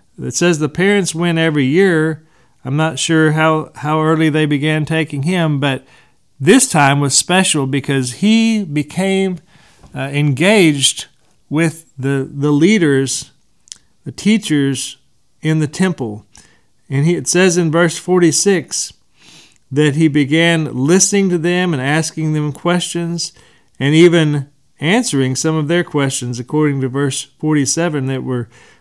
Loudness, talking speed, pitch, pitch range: -14 LUFS, 135 wpm, 155 Hz, 140-170 Hz